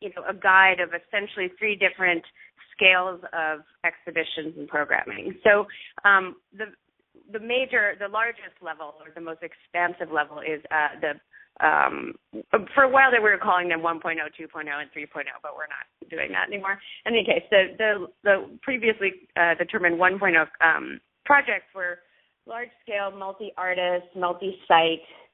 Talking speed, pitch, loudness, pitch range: 155 wpm, 185 Hz, -23 LUFS, 165-205 Hz